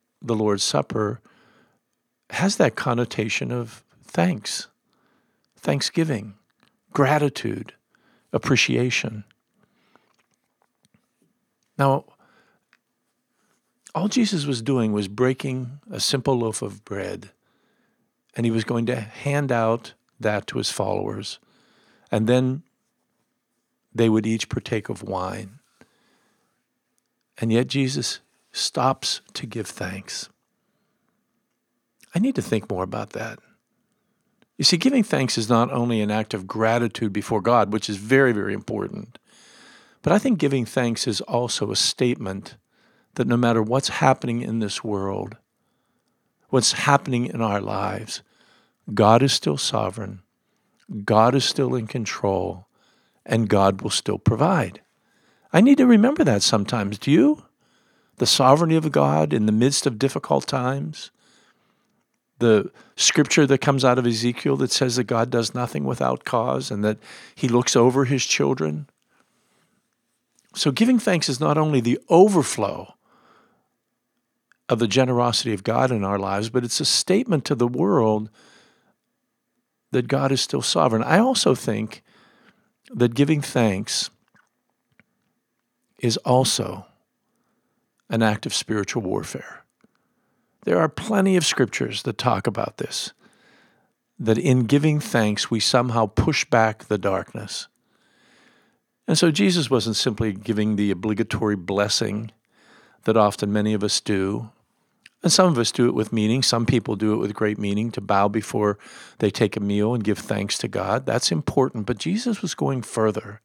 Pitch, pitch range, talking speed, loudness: 120 Hz, 110-135 Hz, 135 wpm, -22 LUFS